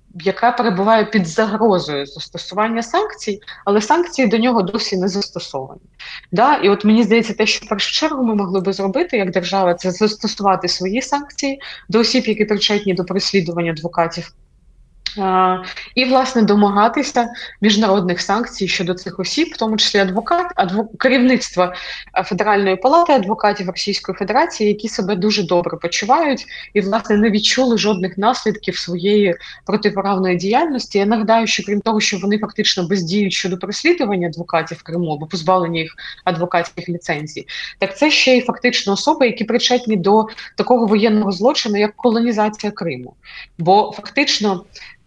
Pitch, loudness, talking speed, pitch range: 210 Hz, -17 LUFS, 145 wpm, 190-230 Hz